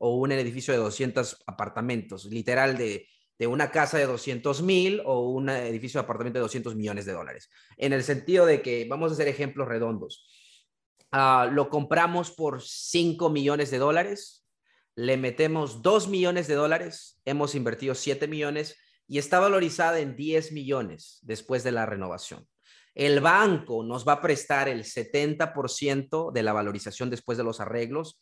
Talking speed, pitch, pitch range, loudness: 165 wpm, 140 Hz, 120-155 Hz, -26 LUFS